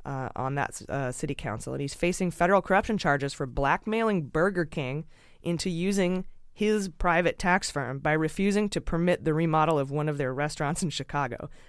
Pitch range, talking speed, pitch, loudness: 140-180 Hz, 180 wpm, 155 Hz, -28 LUFS